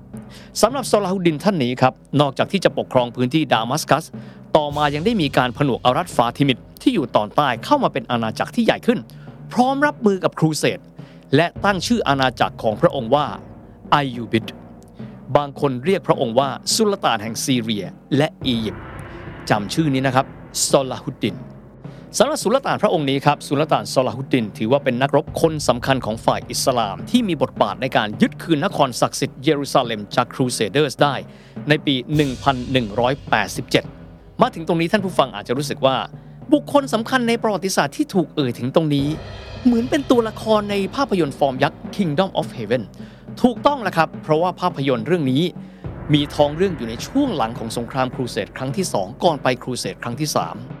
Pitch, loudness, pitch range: 145 Hz, -20 LUFS, 130-190 Hz